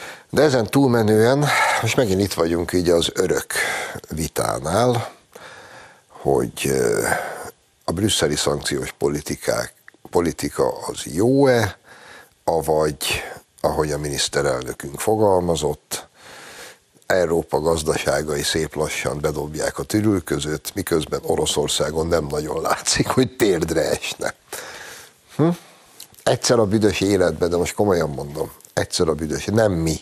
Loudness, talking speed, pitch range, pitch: -21 LUFS, 105 wpm, 85-120 Hz, 105 Hz